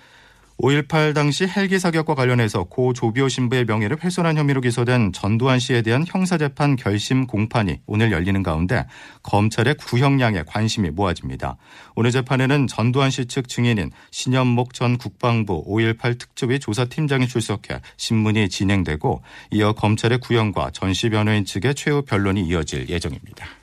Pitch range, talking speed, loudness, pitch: 105-135 Hz, 345 characters per minute, -20 LUFS, 120 Hz